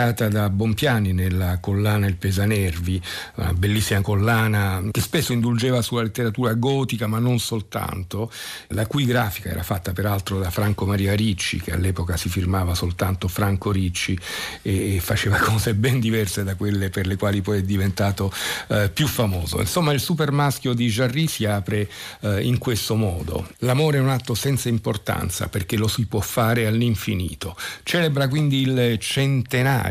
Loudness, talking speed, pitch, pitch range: -22 LUFS, 160 wpm, 105 Hz, 95-120 Hz